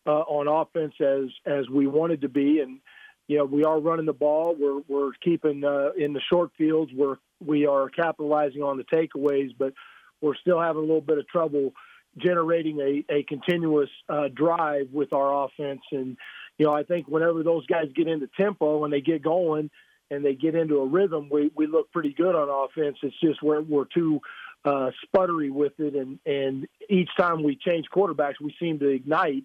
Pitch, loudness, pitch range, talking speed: 150 Hz, -25 LUFS, 140-165 Hz, 200 wpm